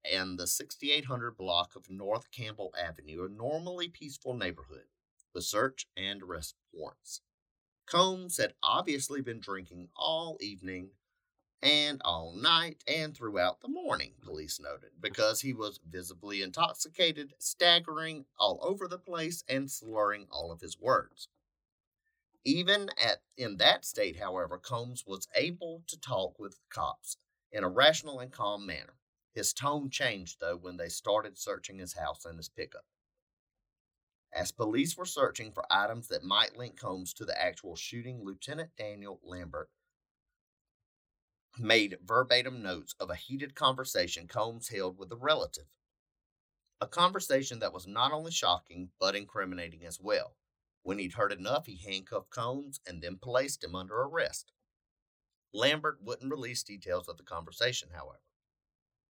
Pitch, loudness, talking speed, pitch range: 120 Hz, -32 LUFS, 145 wpm, 95-155 Hz